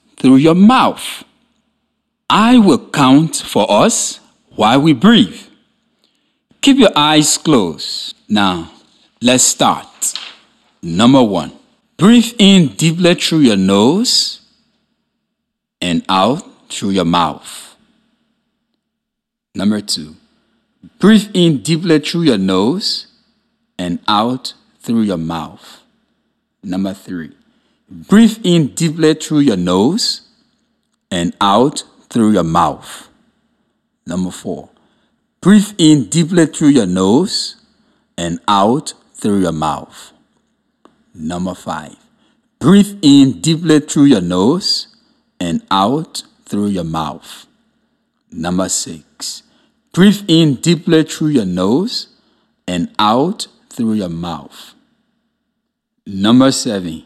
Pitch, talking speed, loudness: 170 Hz, 105 wpm, -13 LUFS